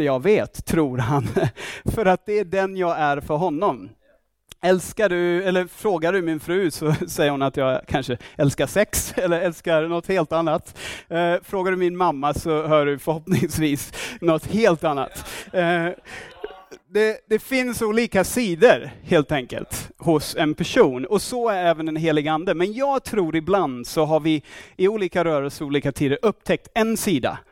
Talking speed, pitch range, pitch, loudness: 165 wpm, 150-190 Hz, 170 Hz, -22 LUFS